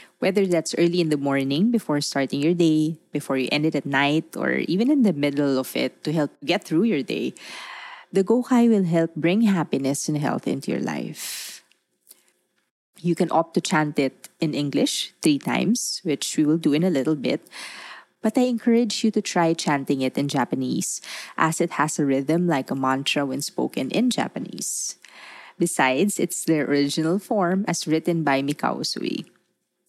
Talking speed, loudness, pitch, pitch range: 180 wpm, -23 LUFS, 160 Hz, 145-195 Hz